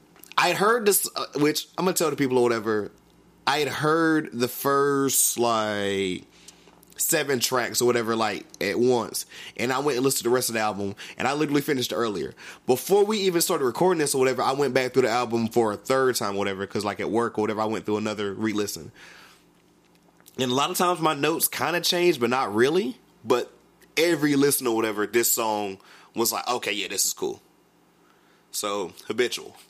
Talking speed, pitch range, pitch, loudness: 210 wpm, 110-150 Hz, 125 Hz, -24 LUFS